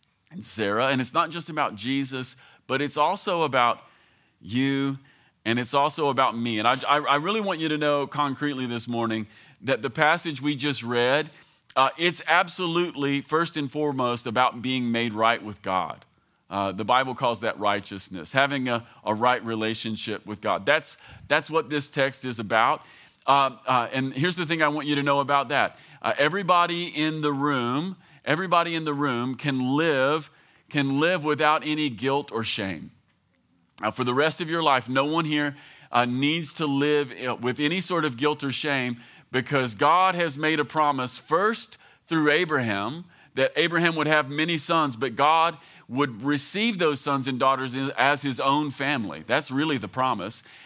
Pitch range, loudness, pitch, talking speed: 125-155 Hz, -24 LUFS, 140 Hz, 180 wpm